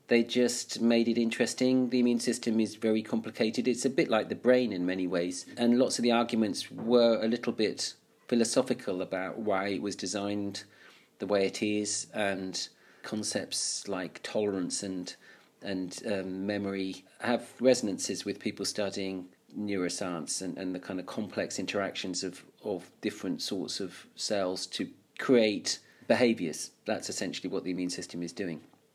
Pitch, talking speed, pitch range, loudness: 105 Hz, 160 wpm, 95-115 Hz, -31 LUFS